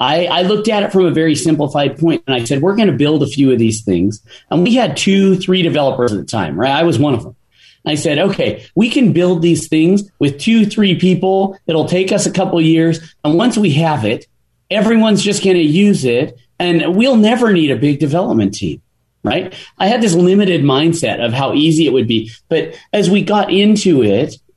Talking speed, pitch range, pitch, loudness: 225 wpm, 145-195 Hz, 170 Hz, -13 LUFS